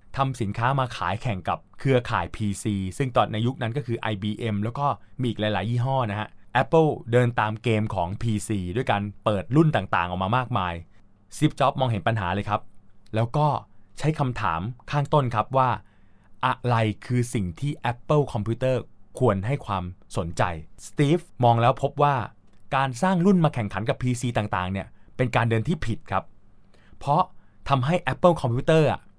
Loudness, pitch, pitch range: -25 LUFS, 115 Hz, 100-130 Hz